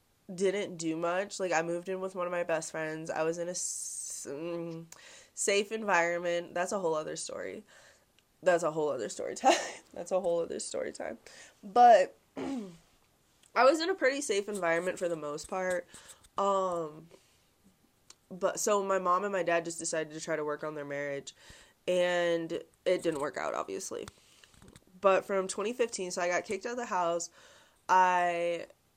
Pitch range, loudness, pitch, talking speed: 165-200 Hz, -31 LUFS, 180 Hz, 175 wpm